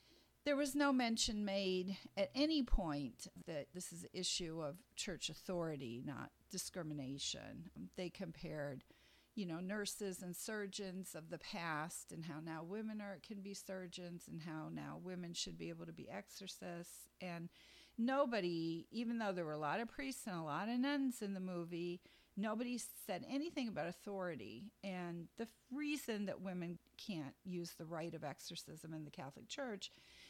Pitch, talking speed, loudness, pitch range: 185 Hz, 170 wpm, -45 LUFS, 165-215 Hz